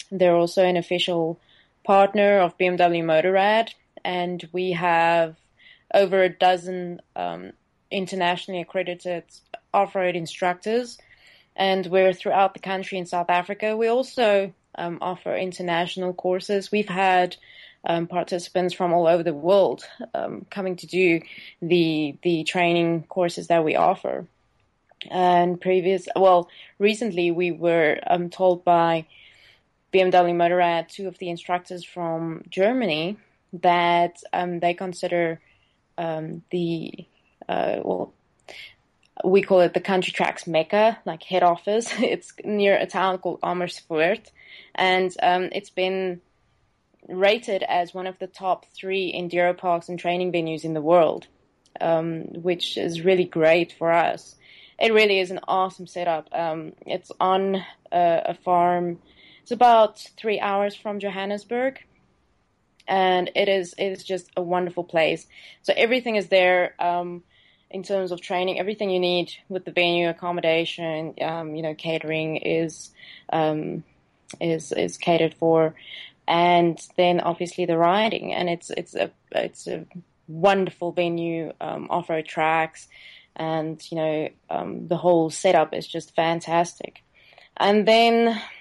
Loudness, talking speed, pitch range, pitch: -23 LUFS, 135 wpm, 170-190 Hz, 175 Hz